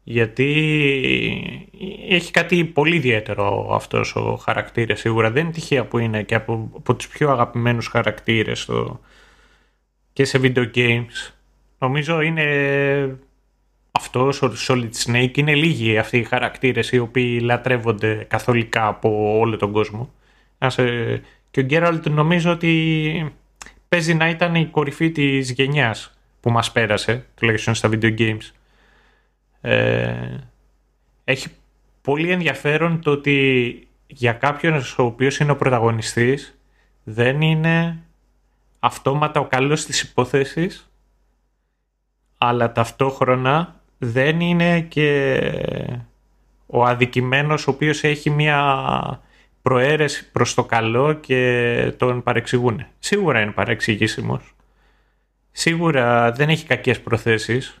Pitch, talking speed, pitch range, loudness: 130 Hz, 115 wpm, 115-150 Hz, -19 LUFS